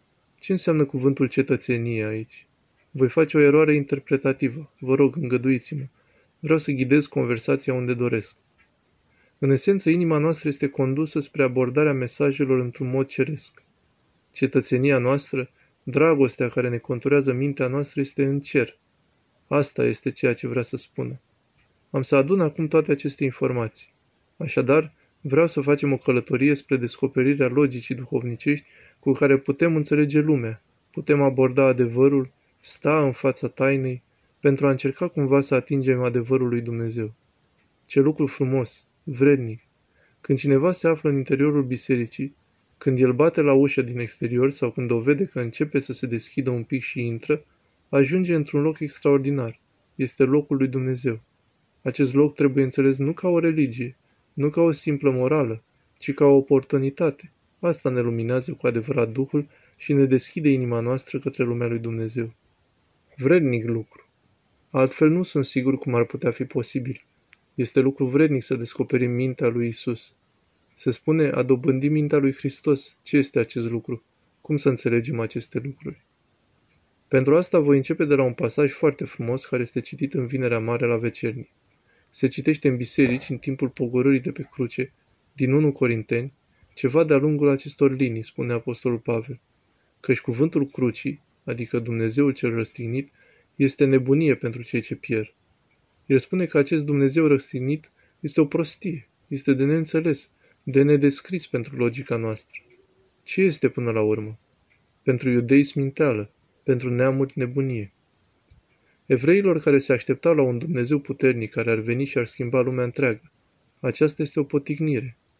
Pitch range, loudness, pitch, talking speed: 125-145 Hz, -23 LUFS, 135 Hz, 155 wpm